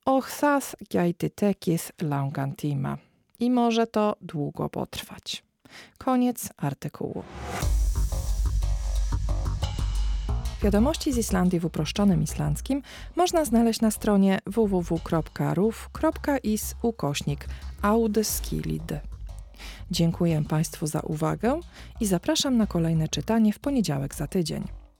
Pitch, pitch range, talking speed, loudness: 170 Hz, 140-225 Hz, 85 wpm, -26 LUFS